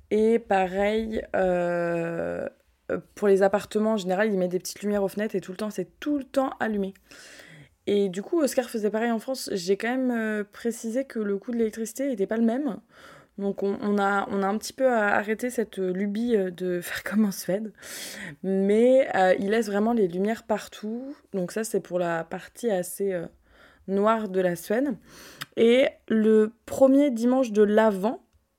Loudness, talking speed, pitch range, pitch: -25 LUFS, 185 wpm, 195-230 Hz, 210 Hz